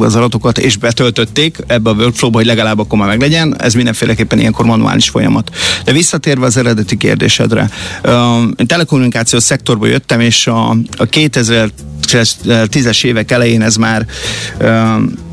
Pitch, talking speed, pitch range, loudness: 115 Hz, 135 wpm, 110-125 Hz, -10 LUFS